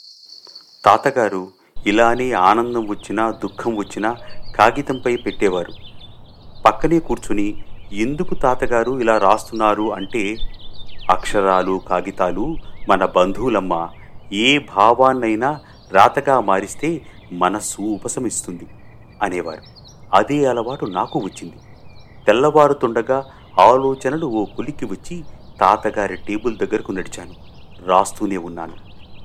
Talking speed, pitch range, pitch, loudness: 85 wpm, 100-125 Hz, 110 Hz, -18 LUFS